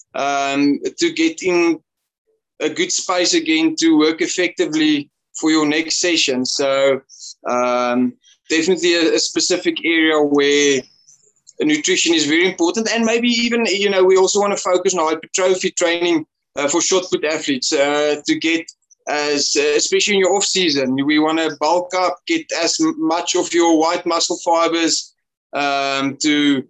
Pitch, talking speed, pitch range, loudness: 170 Hz, 155 wpm, 150-235 Hz, -17 LUFS